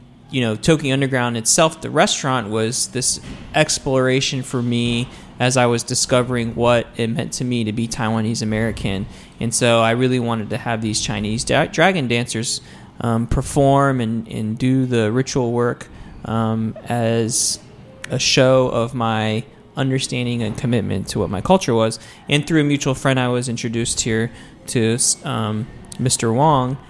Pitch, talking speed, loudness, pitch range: 120 Hz, 160 wpm, -19 LUFS, 115-130 Hz